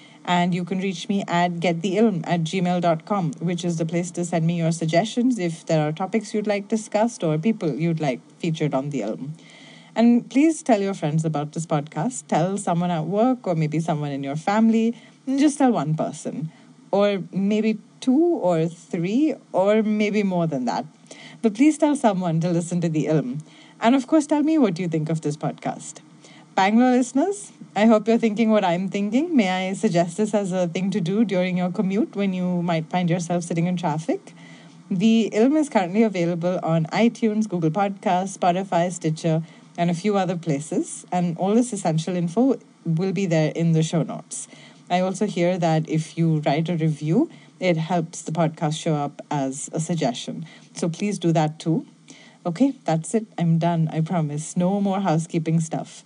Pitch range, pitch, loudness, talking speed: 165-215 Hz, 180 Hz, -22 LUFS, 190 wpm